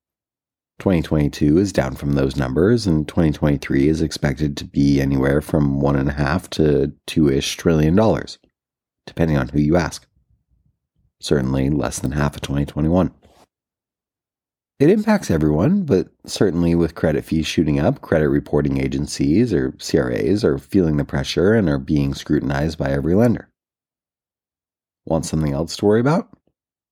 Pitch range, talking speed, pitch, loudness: 70-80 Hz, 145 wpm, 75 Hz, -19 LUFS